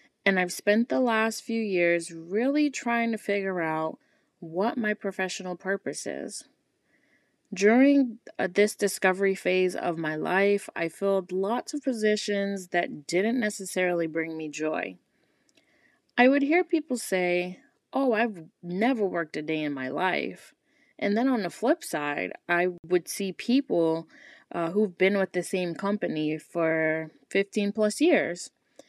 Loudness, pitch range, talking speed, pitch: -27 LUFS, 175-230 Hz, 145 wpm, 195 Hz